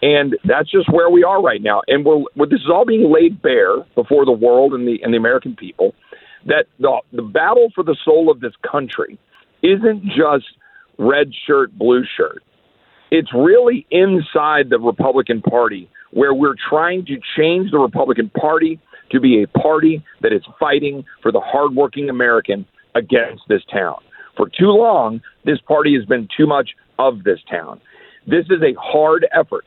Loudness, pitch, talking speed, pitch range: -15 LUFS, 155 Hz, 175 wpm, 130-190 Hz